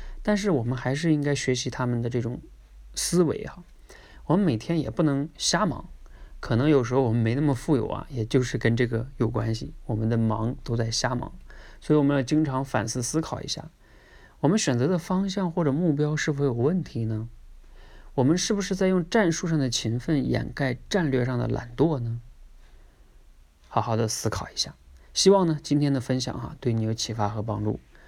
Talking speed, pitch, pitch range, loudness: 290 characters per minute, 130 Hz, 115-150 Hz, -26 LUFS